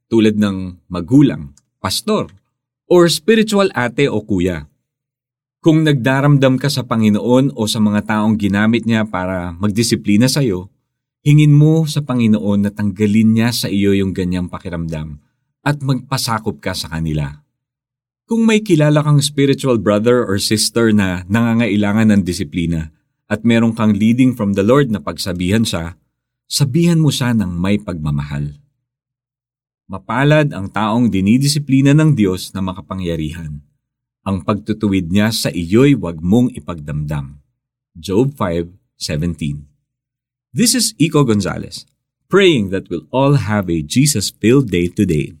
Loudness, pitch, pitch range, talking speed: -15 LUFS, 110 Hz, 95-130 Hz, 135 wpm